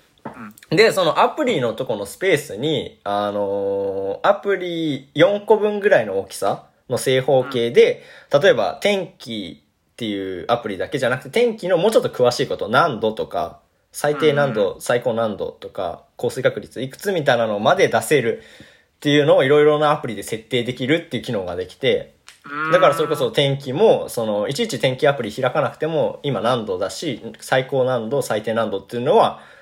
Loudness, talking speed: -19 LUFS, 355 characters per minute